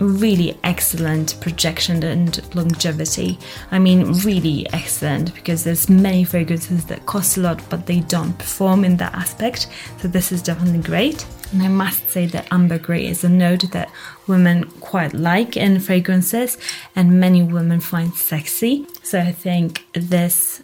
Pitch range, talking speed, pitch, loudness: 170-185 Hz, 155 wpm, 175 Hz, -18 LUFS